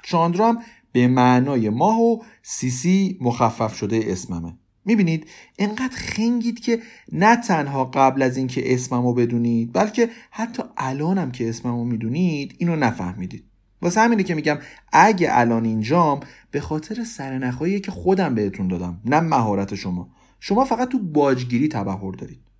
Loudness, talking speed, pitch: -21 LUFS, 140 wpm, 140 Hz